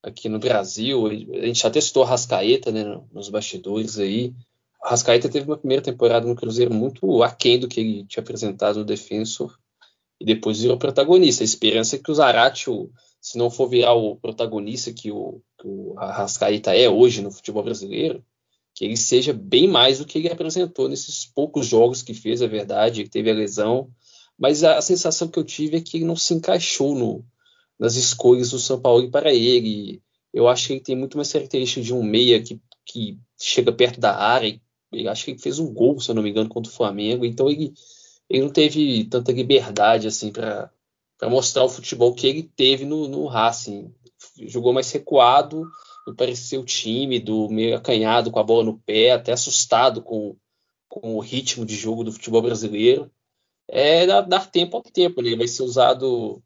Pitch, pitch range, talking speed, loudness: 125 Hz, 115-145 Hz, 190 wpm, -20 LUFS